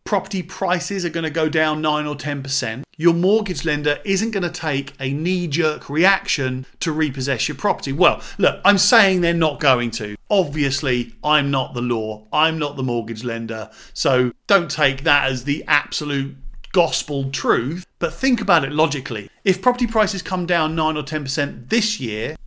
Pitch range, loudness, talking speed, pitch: 135-180 Hz, -20 LUFS, 180 wpm, 150 Hz